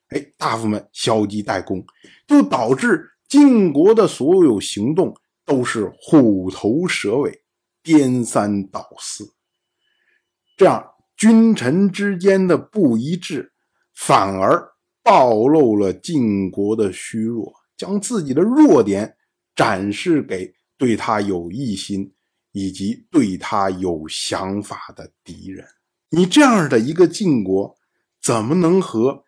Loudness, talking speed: -17 LUFS, 170 characters per minute